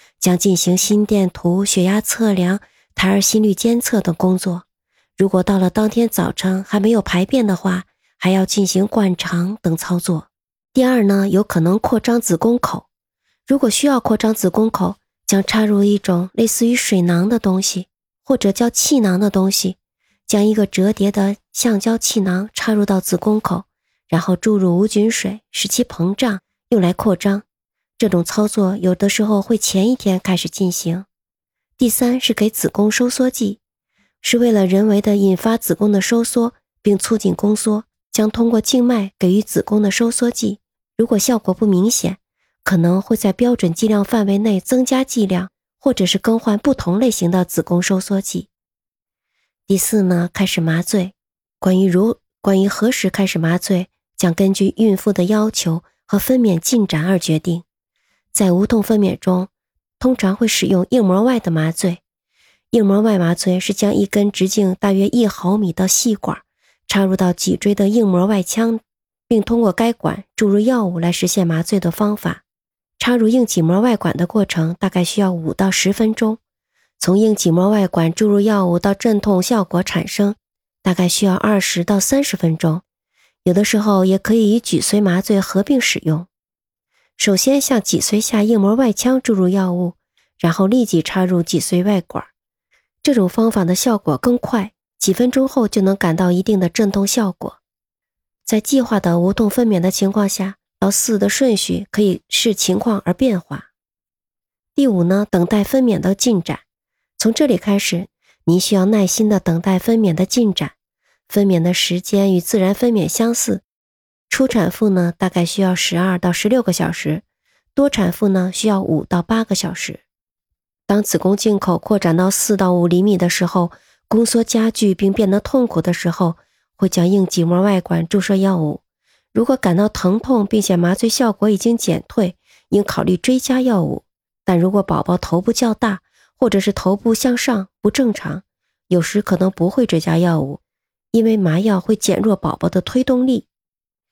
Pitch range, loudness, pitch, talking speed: 185-220 Hz, -16 LUFS, 200 Hz, 255 characters per minute